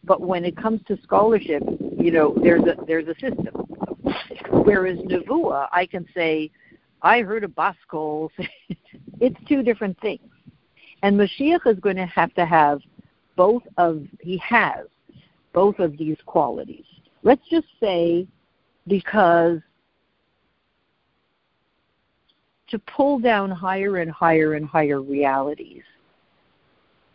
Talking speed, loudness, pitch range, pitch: 120 wpm, -21 LUFS, 165-210 Hz, 185 Hz